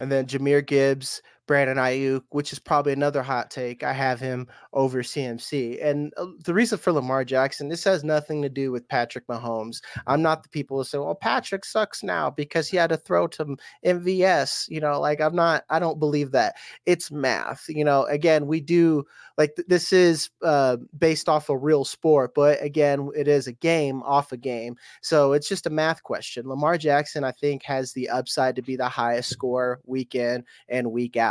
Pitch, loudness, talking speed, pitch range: 145 Hz, -24 LUFS, 200 wpm, 130-155 Hz